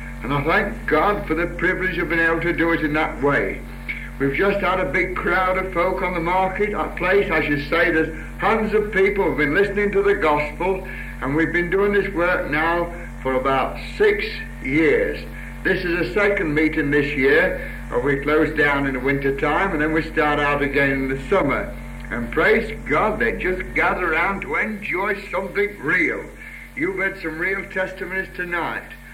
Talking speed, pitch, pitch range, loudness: 195 wpm, 170 Hz, 150-190 Hz, -20 LUFS